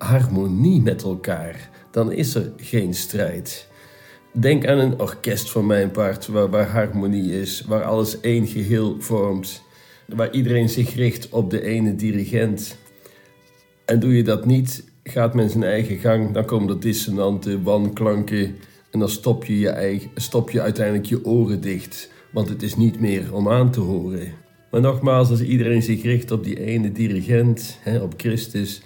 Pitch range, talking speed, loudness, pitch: 100-120 Hz, 165 wpm, -21 LUFS, 110 Hz